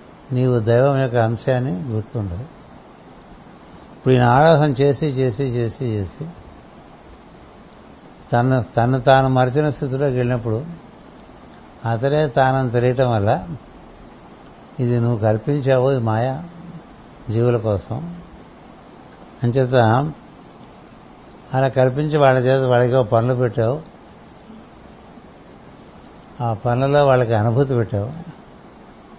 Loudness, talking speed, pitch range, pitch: -18 LUFS, 85 wpm, 120-140 Hz, 130 Hz